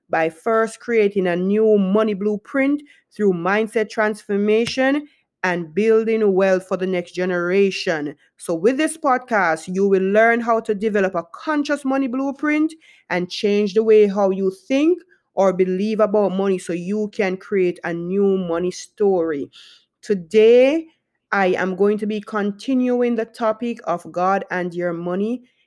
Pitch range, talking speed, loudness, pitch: 185-235 Hz, 150 wpm, -19 LUFS, 210 Hz